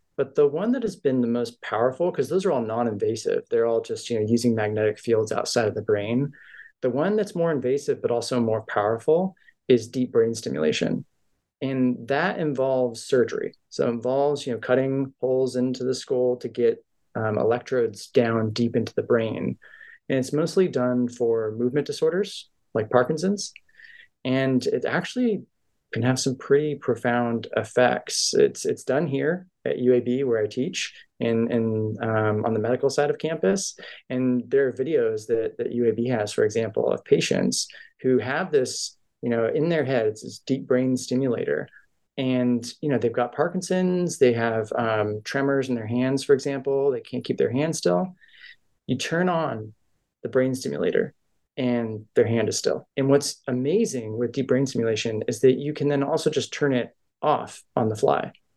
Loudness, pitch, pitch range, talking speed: -24 LUFS, 130 Hz, 120-160 Hz, 175 wpm